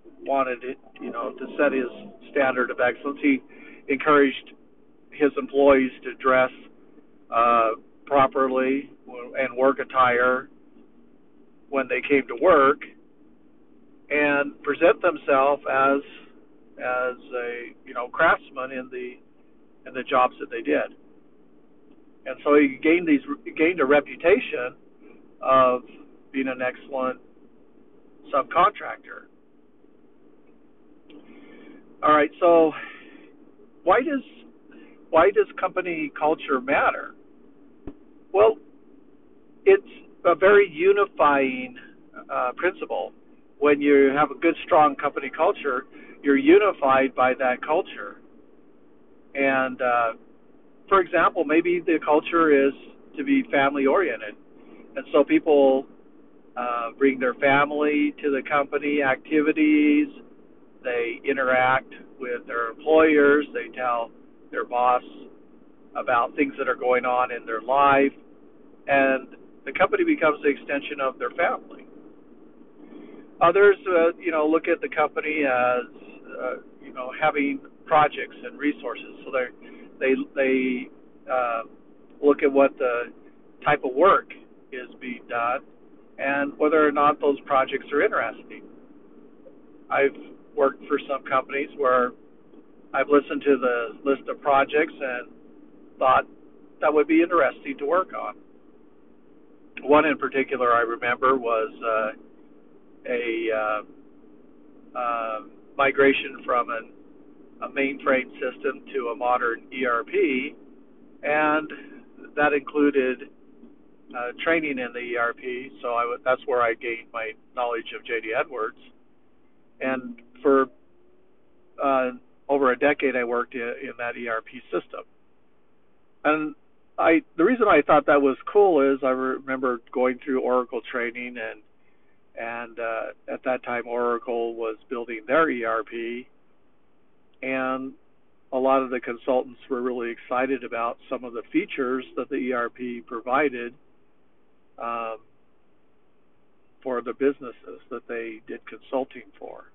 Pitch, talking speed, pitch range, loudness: 135 Hz, 120 wpm, 125-150 Hz, -23 LUFS